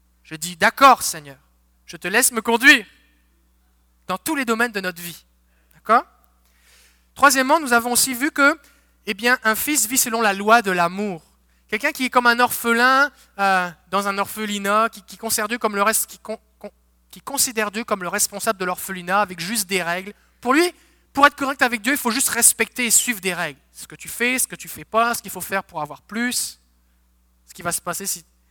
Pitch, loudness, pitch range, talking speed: 205 Hz, -19 LUFS, 170-240 Hz, 210 wpm